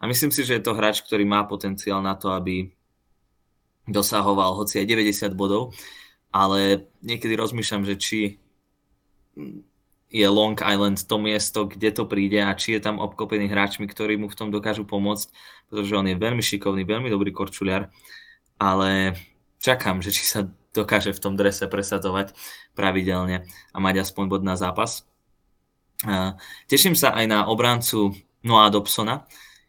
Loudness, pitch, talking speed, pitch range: -22 LUFS, 100 Hz, 150 wpm, 95-105 Hz